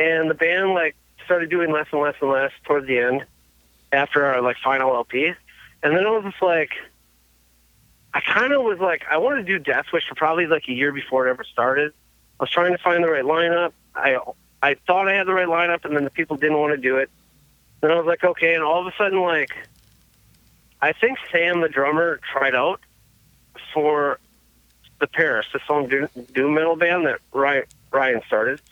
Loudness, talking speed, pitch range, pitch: -20 LUFS, 205 wpm, 135-175 Hz, 155 Hz